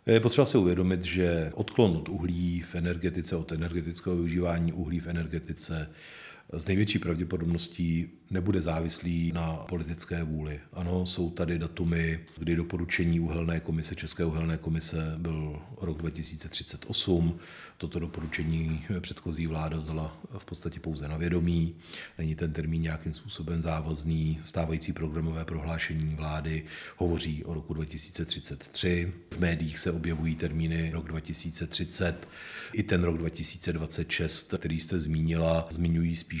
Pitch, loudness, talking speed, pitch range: 85 Hz, -31 LUFS, 130 wpm, 80-85 Hz